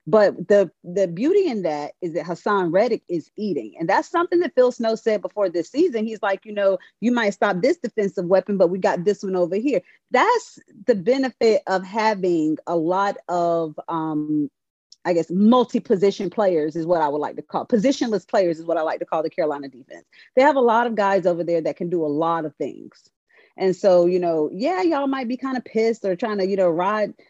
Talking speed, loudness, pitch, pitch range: 225 wpm, -21 LUFS, 200 Hz, 175-235 Hz